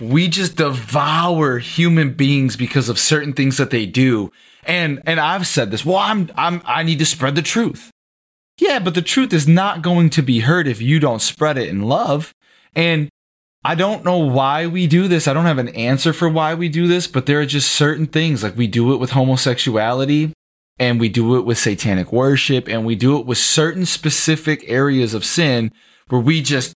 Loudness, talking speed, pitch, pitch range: -16 LUFS, 210 wpm, 145 Hz, 125-165 Hz